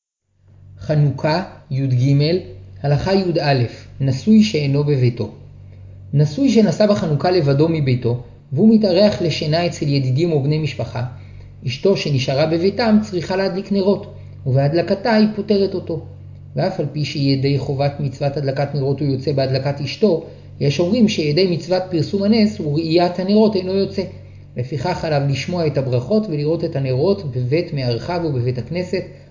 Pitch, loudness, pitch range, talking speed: 150 Hz, -18 LUFS, 130-180 Hz, 130 wpm